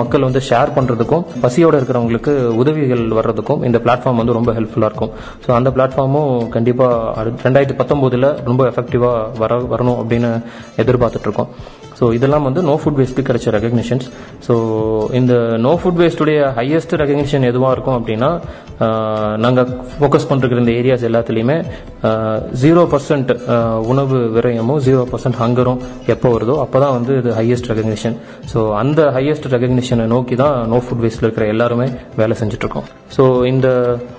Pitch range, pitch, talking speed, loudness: 115-135 Hz, 125 Hz, 140 wpm, -15 LUFS